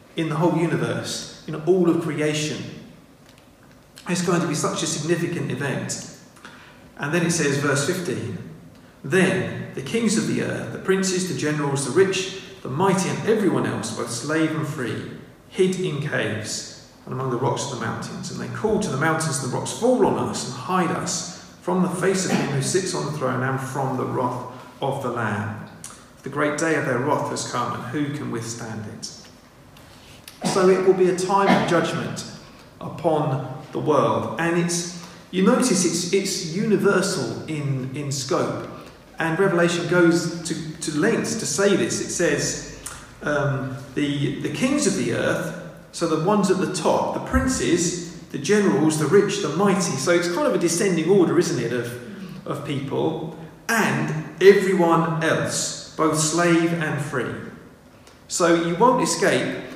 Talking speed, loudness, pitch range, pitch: 175 wpm, -22 LUFS, 145-185 Hz, 165 Hz